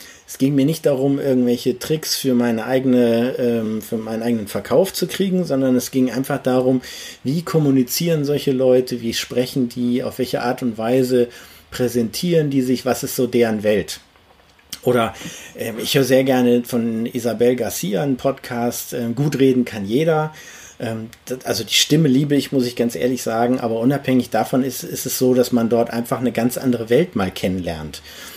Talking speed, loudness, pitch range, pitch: 175 wpm, -19 LUFS, 120-135 Hz, 125 Hz